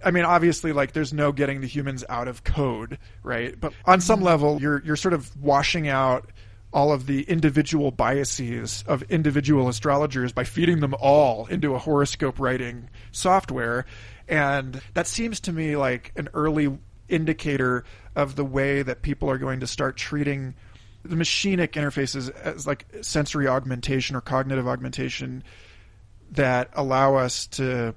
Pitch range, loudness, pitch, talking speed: 125-150 Hz, -24 LUFS, 135 Hz, 155 wpm